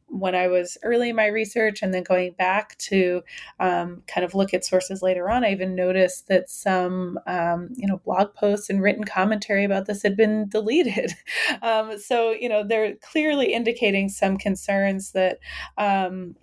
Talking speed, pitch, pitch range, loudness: 180 wpm, 195 Hz, 185-215 Hz, -23 LUFS